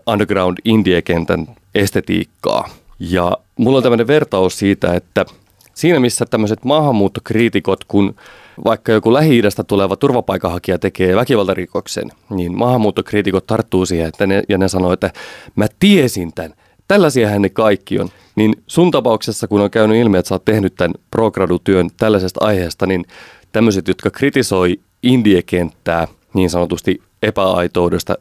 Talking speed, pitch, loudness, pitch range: 130 wpm, 100 Hz, -15 LUFS, 90-115 Hz